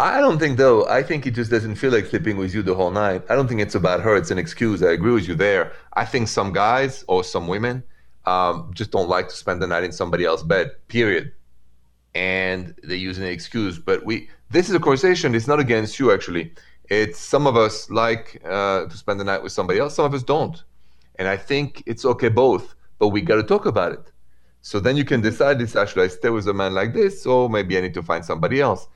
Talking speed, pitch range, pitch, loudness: 245 wpm, 90-130 Hz, 105 Hz, -20 LUFS